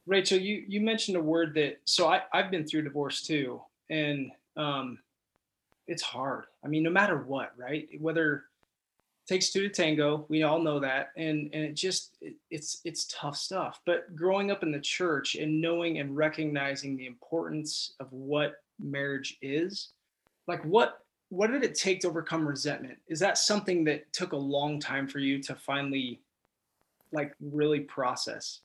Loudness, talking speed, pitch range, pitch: -30 LUFS, 175 wpm, 140-175 Hz, 155 Hz